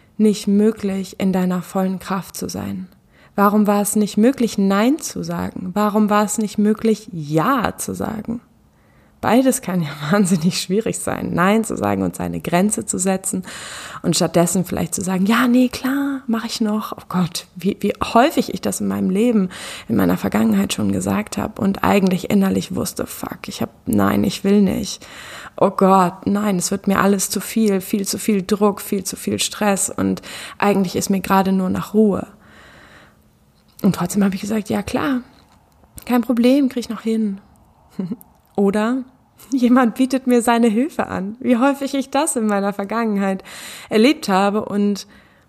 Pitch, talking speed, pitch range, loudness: 205 Hz, 175 wpm, 190-225 Hz, -19 LUFS